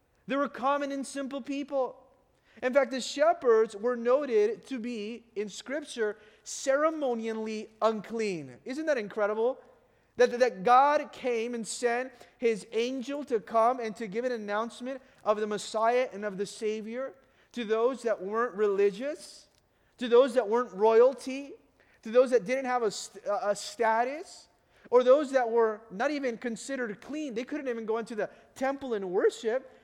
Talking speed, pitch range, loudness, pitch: 155 wpm, 220-265 Hz, -29 LUFS, 240 Hz